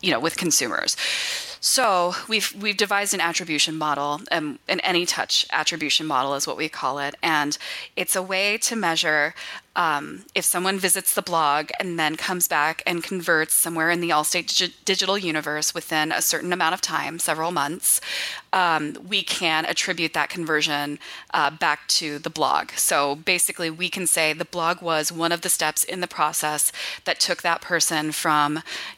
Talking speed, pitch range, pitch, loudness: 175 wpm, 150-180 Hz, 165 Hz, -22 LUFS